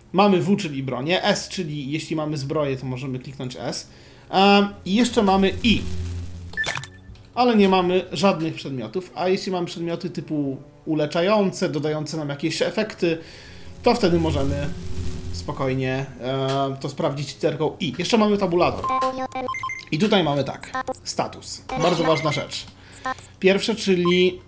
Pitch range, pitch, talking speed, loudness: 135-195 Hz, 165 Hz, 130 wpm, -23 LUFS